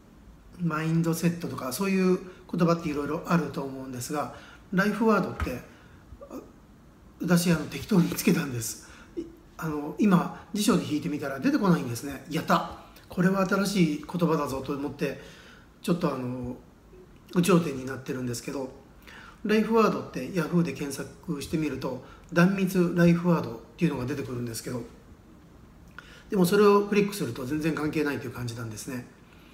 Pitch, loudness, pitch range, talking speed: 155 Hz, -27 LUFS, 135-180 Hz, 340 characters per minute